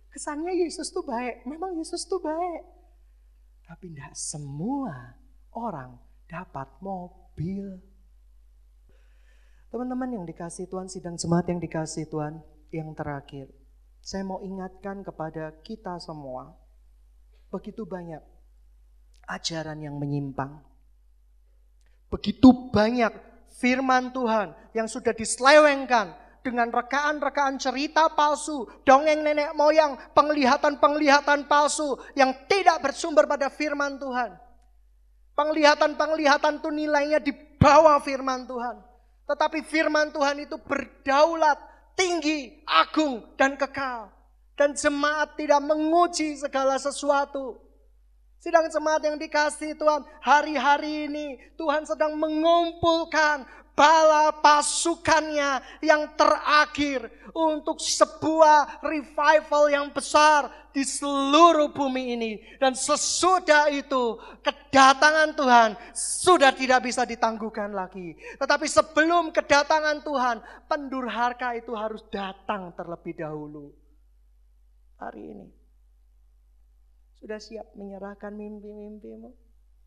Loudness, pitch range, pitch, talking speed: -23 LUFS, 190-300 Hz, 265 Hz, 95 wpm